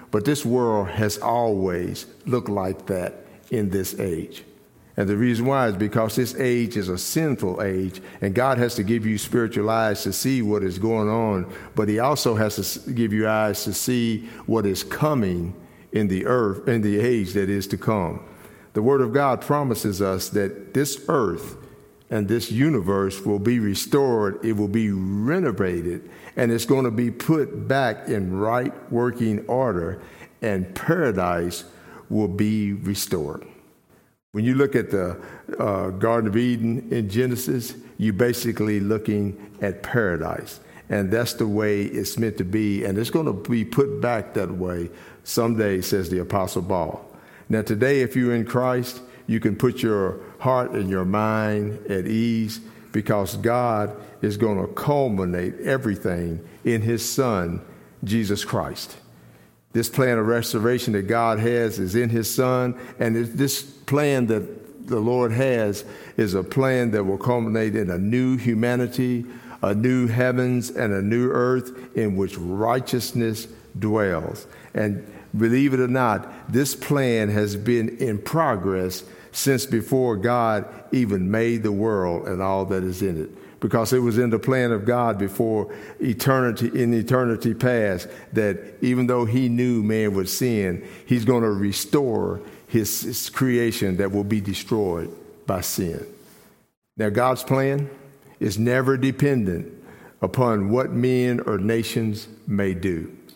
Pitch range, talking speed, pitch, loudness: 100-125 Hz, 155 wpm, 110 Hz, -23 LUFS